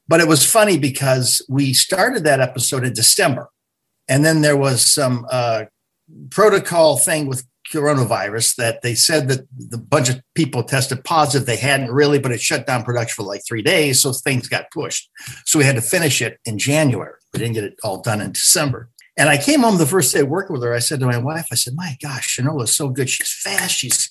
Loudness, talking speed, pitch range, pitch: -16 LUFS, 225 wpm, 120-150 Hz, 135 Hz